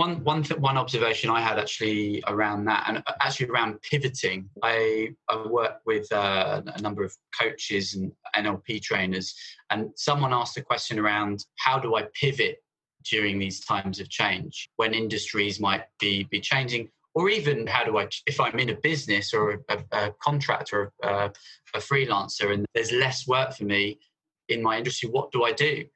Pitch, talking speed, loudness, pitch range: 110 Hz, 180 wpm, -26 LUFS, 105-135 Hz